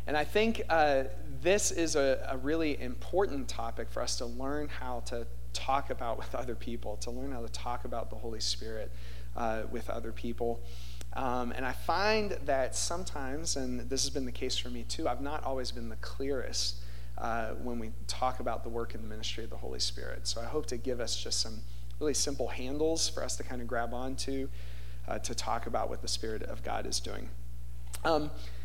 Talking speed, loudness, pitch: 210 wpm, -34 LUFS, 120 Hz